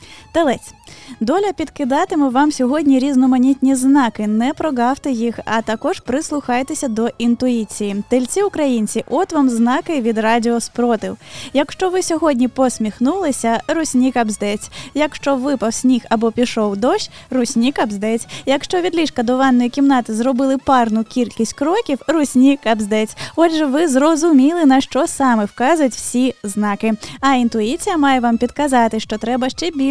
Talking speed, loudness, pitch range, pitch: 135 wpm, -16 LUFS, 230-290 Hz, 260 Hz